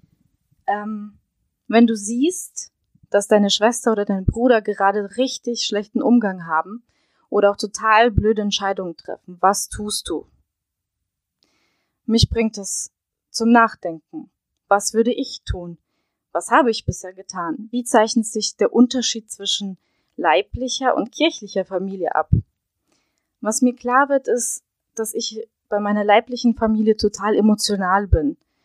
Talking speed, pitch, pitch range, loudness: 130 wpm, 220 Hz, 200-240 Hz, -19 LUFS